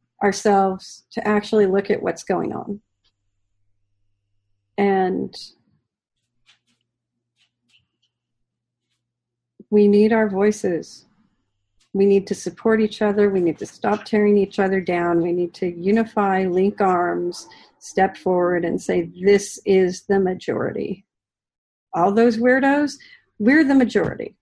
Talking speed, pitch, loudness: 115 wpm, 185 Hz, -20 LUFS